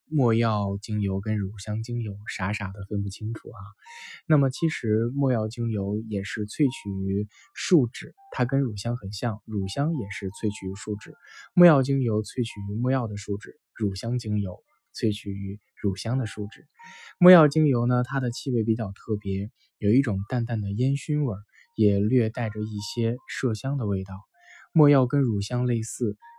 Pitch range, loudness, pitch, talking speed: 105-130 Hz, -26 LUFS, 110 Hz, 250 characters per minute